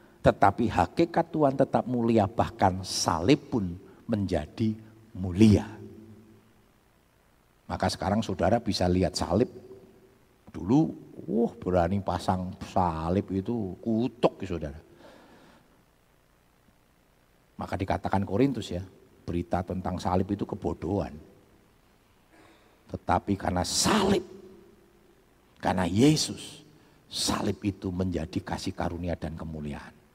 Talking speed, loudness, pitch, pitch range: 95 wpm, -28 LUFS, 100 Hz, 90-115 Hz